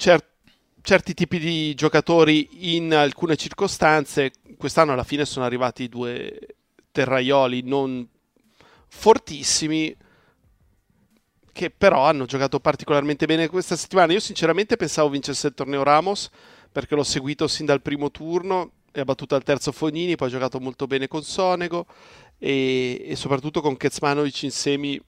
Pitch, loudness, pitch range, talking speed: 150 Hz, -22 LUFS, 140-165 Hz, 135 wpm